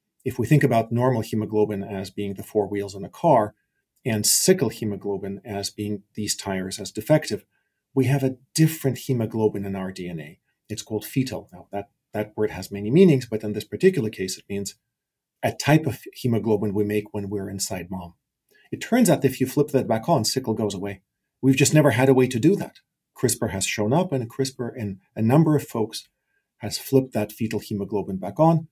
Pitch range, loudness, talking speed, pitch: 100-135 Hz, -23 LUFS, 205 wpm, 110 Hz